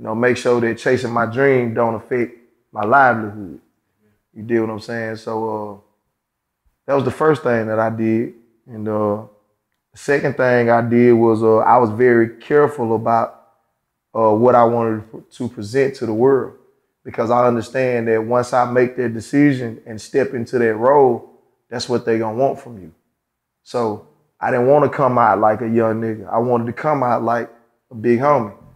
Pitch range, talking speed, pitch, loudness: 110-125 Hz, 190 wpm, 115 Hz, -17 LUFS